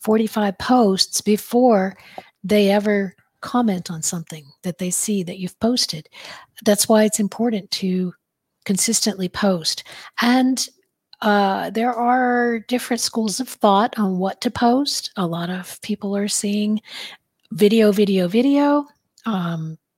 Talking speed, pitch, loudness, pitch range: 130 wpm, 210 Hz, -19 LUFS, 190-235 Hz